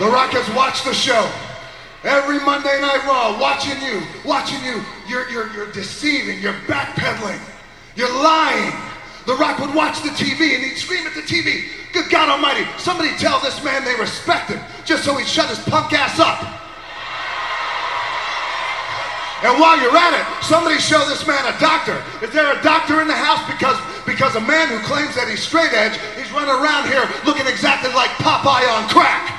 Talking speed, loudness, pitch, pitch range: 185 wpm, -17 LUFS, 280 Hz, 255-310 Hz